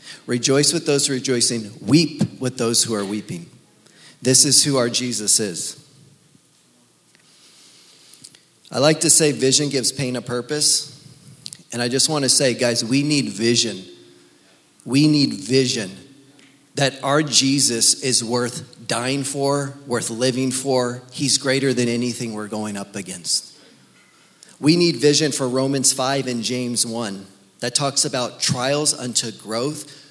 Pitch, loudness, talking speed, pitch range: 130 Hz, -19 LUFS, 140 wpm, 120-145 Hz